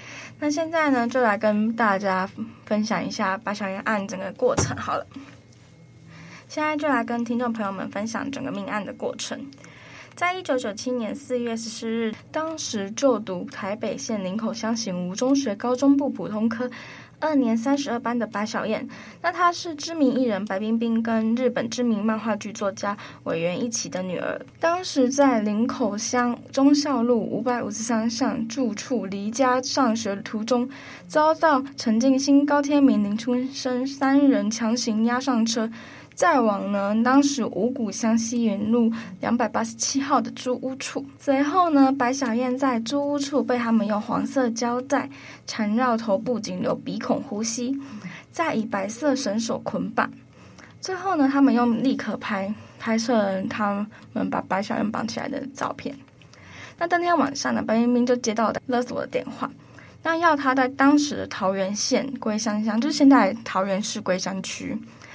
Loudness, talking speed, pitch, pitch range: -24 LUFS, 250 characters per minute, 240 Hz, 220-270 Hz